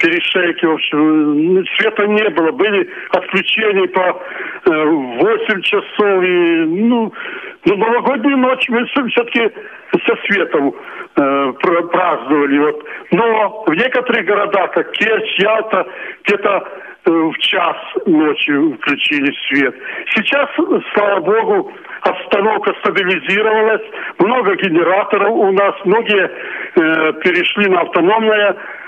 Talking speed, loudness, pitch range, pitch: 105 wpm, -14 LUFS, 185-305 Hz, 215 Hz